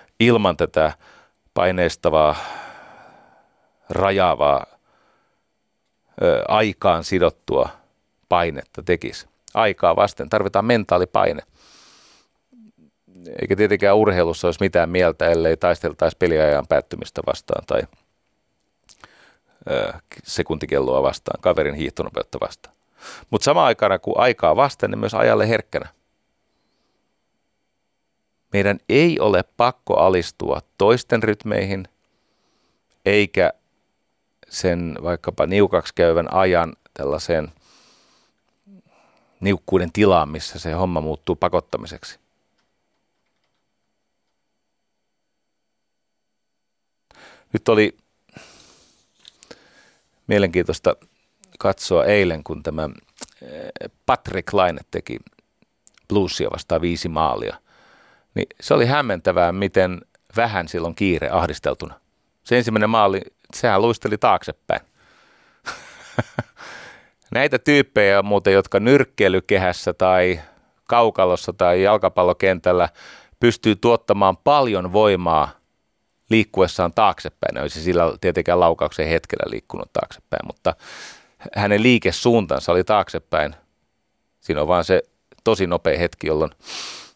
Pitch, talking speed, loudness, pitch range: 95 Hz, 85 wpm, -19 LUFS, 85-105 Hz